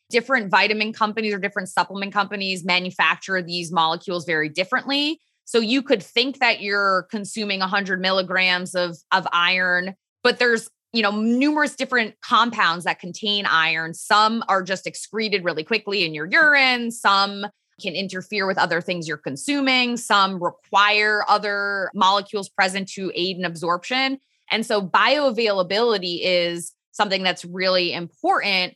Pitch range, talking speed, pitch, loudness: 180-225 Hz, 140 wpm, 200 Hz, -20 LUFS